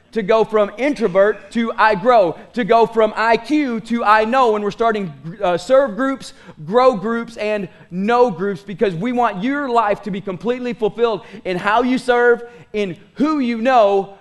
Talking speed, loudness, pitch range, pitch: 175 wpm, -17 LUFS, 200-240 Hz, 225 Hz